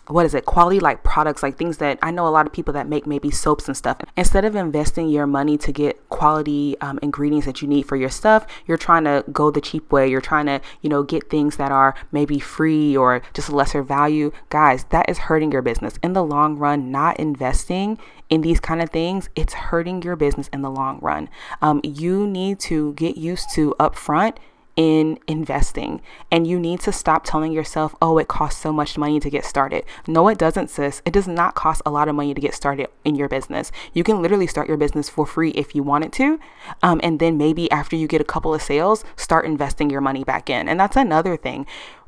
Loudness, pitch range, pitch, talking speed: -20 LUFS, 145-165 Hz, 150 Hz, 230 wpm